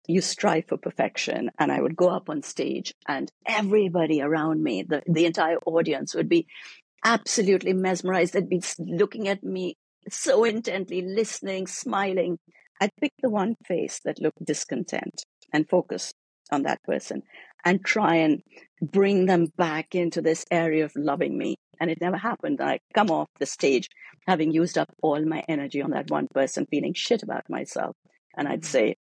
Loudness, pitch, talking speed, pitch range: -25 LUFS, 180 Hz, 170 wpm, 160-195 Hz